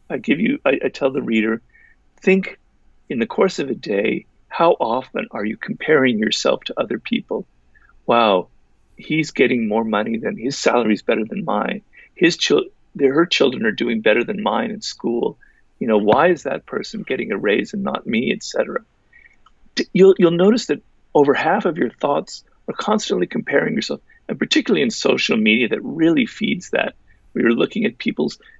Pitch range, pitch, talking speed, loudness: 135-225 Hz, 195 Hz, 185 wpm, -19 LUFS